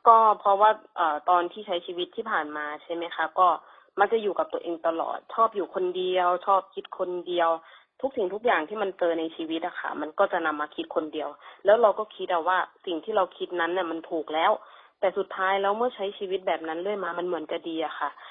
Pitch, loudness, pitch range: 180 Hz, -27 LUFS, 165-200 Hz